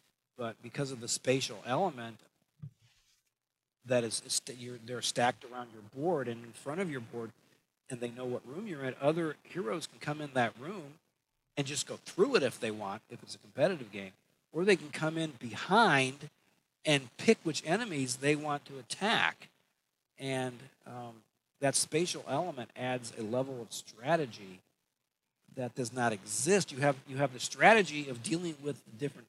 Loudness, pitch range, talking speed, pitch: -33 LUFS, 120-150 Hz, 175 wpm, 130 Hz